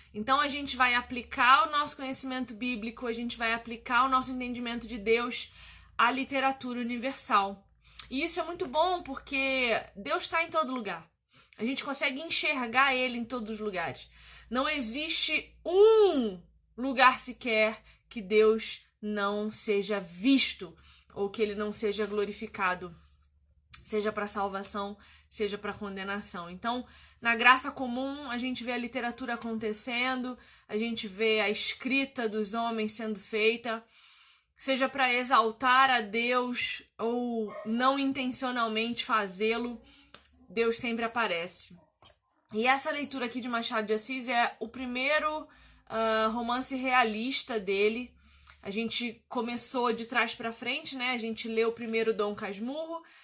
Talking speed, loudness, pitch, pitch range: 140 wpm, -29 LUFS, 235 Hz, 220-260 Hz